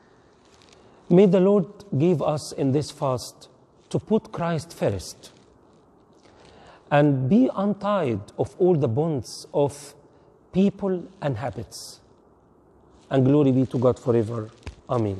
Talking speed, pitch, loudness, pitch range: 120 wpm, 145 Hz, -23 LUFS, 125-180 Hz